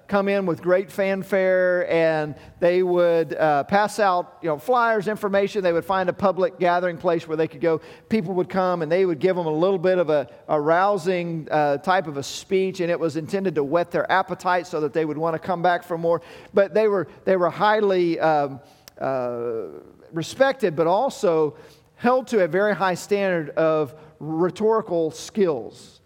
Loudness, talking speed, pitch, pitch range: -22 LUFS, 195 wpm, 175 Hz, 160-195 Hz